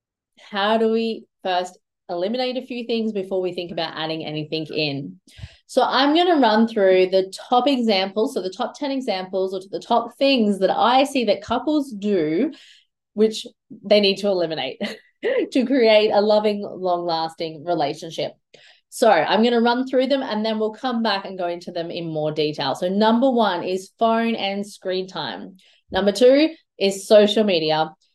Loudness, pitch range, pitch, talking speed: -21 LUFS, 180-235 Hz, 205 Hz, 175 wpm